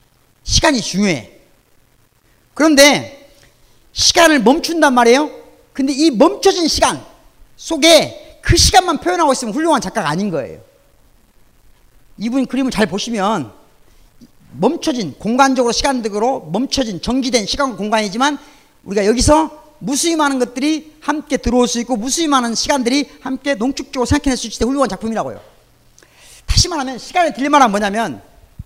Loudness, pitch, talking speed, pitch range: -15 LUFS, 265 Hz, 325 characters per minute, 230-295 Hz